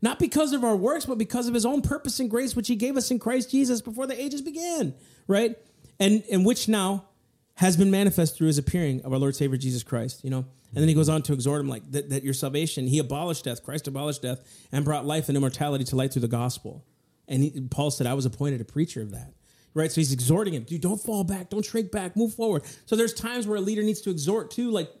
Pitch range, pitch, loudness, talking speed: 140-225 Hz, 160 Hz, -26 LUFS, 260 wpm